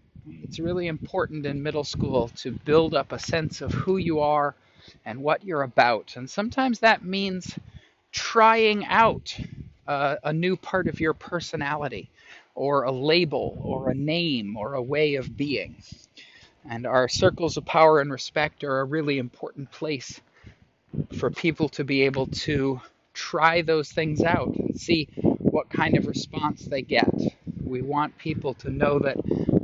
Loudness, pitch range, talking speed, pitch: -25 LUFS, 135-165 Hz, 160 wpm, 150 Hz